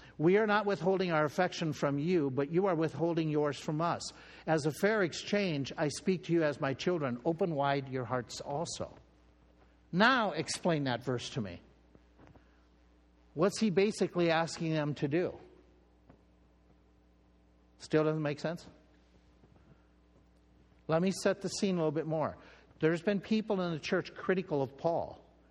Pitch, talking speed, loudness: 150 Hz, 155 wpm, -32 LUFS